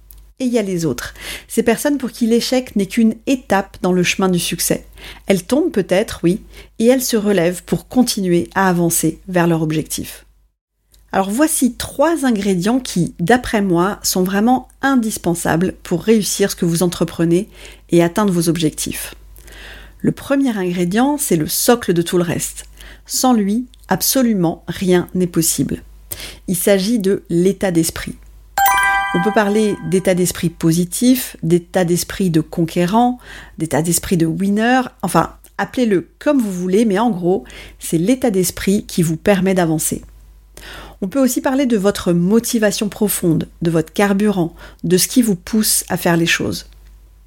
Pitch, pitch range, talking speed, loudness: 190 Hz, 175-230 Hz, 155 wpm, -16 LUFS